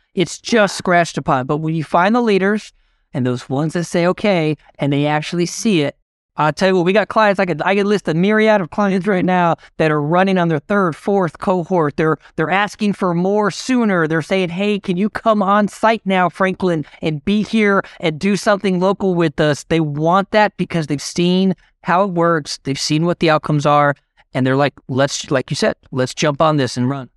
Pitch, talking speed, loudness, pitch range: 175 Hz, 220 wpm, -17 LUFS, 155-200 Hz